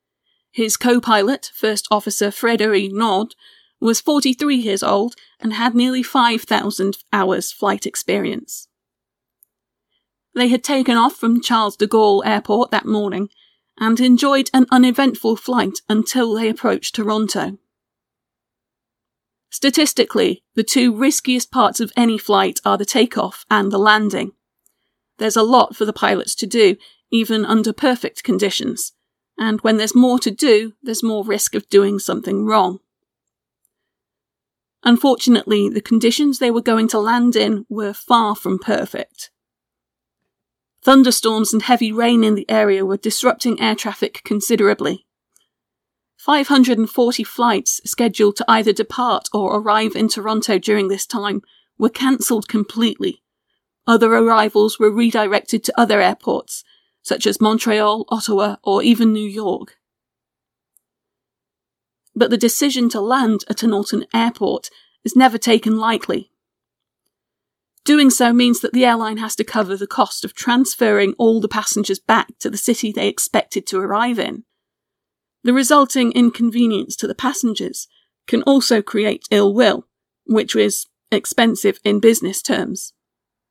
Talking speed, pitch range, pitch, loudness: 135 wpm, 210-240 Hz, 225 Hz, -16 LUFS